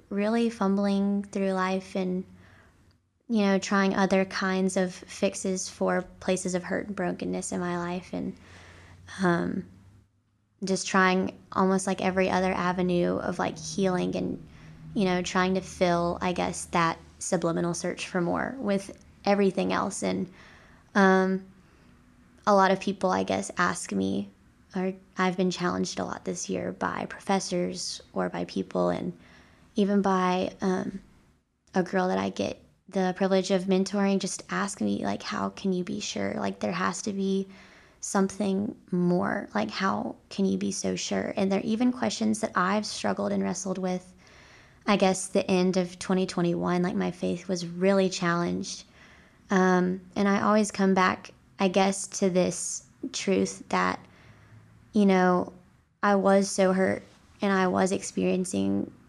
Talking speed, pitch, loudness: 155 wpm, 185 Hz, -27 LUFS